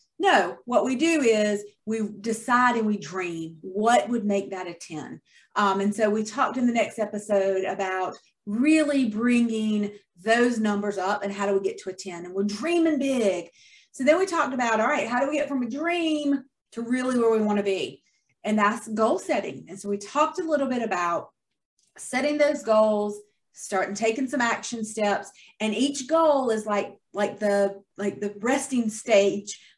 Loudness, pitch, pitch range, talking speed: -25 LUFS, 215 Hz, 200-255 Hz, 190 wpm